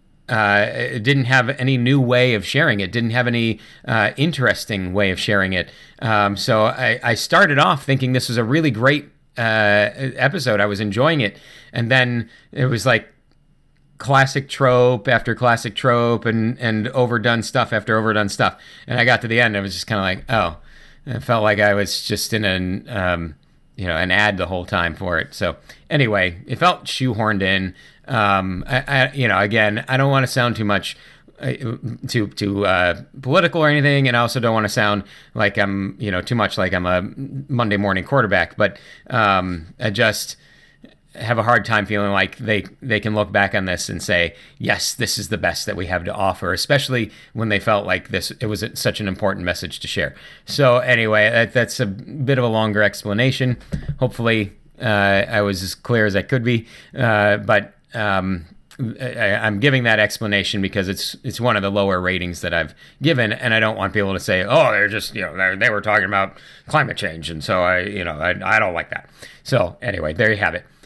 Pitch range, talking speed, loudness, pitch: 100-125 Hz, 210 wpm, -18 LUFS, 110 Hz